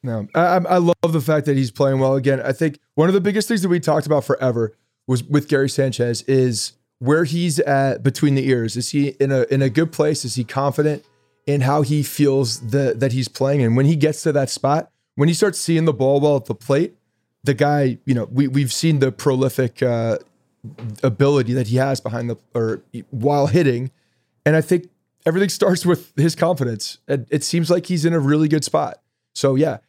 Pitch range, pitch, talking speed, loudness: 130-155 Hz, 140 Hz, 215 wpm, -19 LUFS